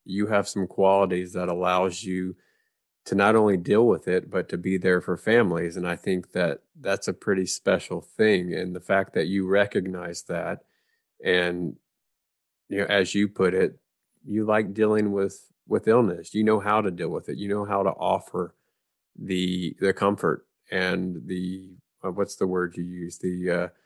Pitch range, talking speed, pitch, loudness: 90-100 Hz, 185 wpm, 95 Hz, -25 LUFS